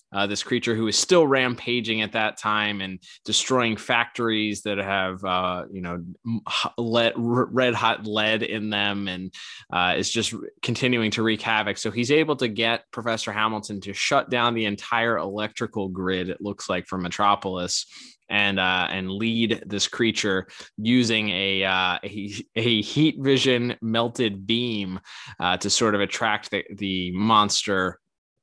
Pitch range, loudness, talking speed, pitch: 100-115 Hz, -23 LUFS, 155 wpm, 110 Hz